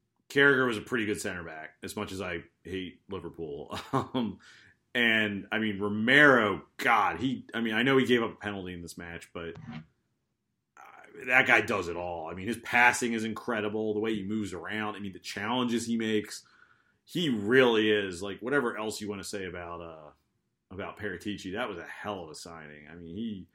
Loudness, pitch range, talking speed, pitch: -28 LUFS, 90-110 Hz, 205 wpm, 105 Hz